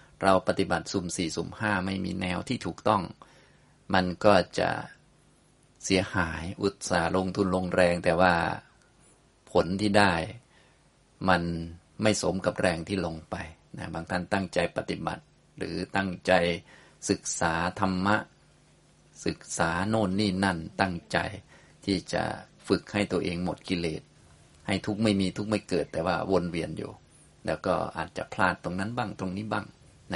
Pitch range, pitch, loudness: 85-100 Hz, 95 Hz, -28 LUFS